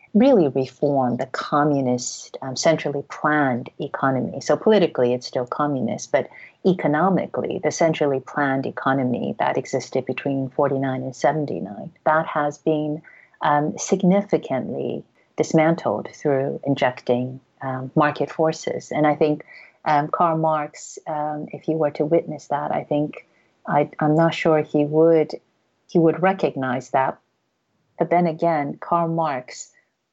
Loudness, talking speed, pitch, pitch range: -22 LUFS, 130 wpm, 150 Hz, 135-160 Hz